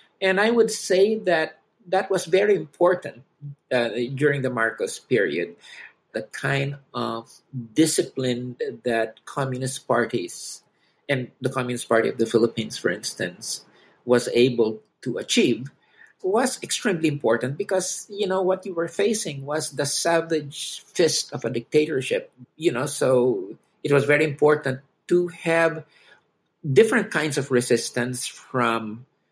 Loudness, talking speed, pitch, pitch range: -23 LUFS, 135 wpm, 145 Hz, 125-185 Hz